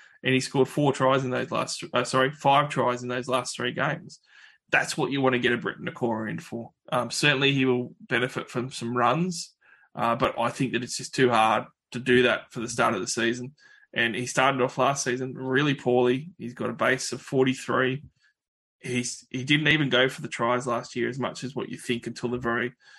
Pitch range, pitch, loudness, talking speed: 120-130 Hz, 125 Hz, -25 LUFS, 225 wpm